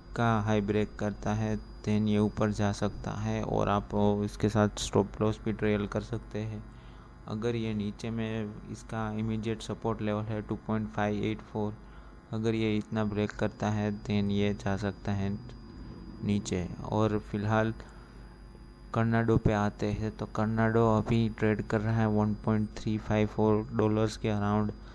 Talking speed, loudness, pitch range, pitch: 165 wpm, -31 LUFS, 105-110 Hz, 105 Hz